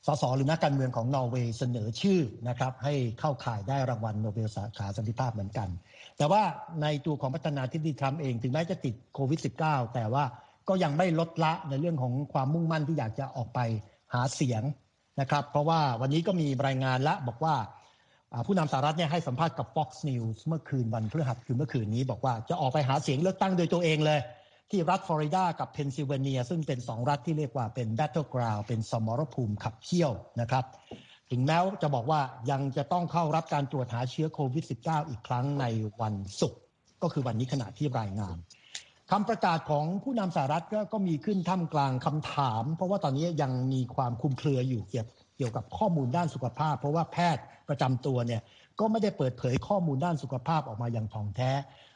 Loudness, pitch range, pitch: -31 LUFS, 125-160 Hz, 140 Hz